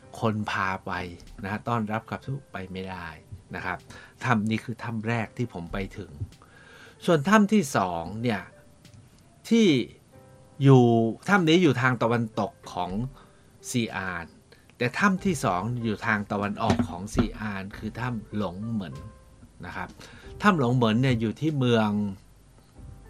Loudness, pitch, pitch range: -26 LUFS, 115 Hz, 105-125 Hz